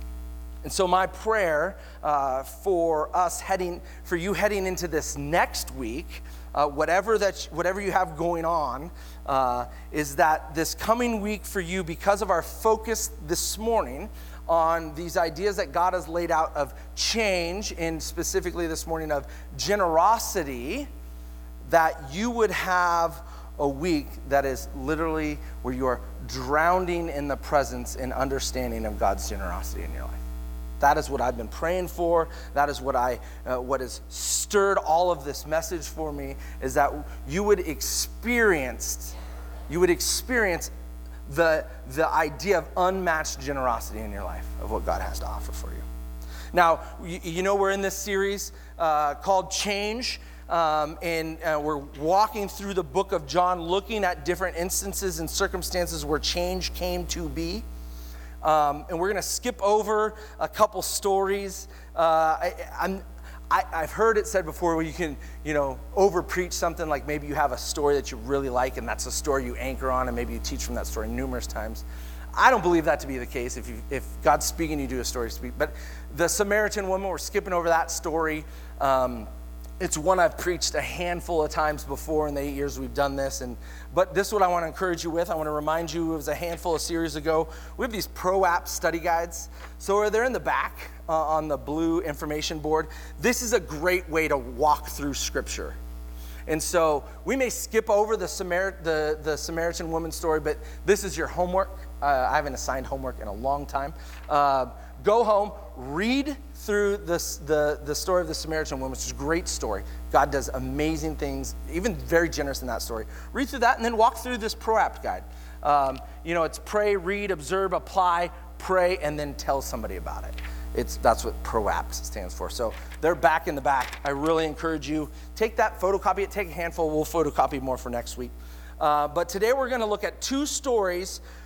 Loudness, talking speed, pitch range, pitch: -26 LUFS, 190 wpm, 130-185 Hz, 160 Hz